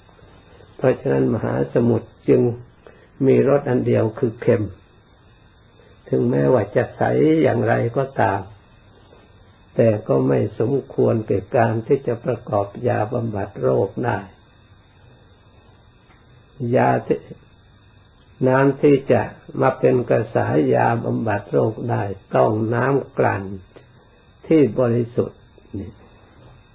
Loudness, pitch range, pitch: -20 LUFS, 100-120 Hz, 115 Hz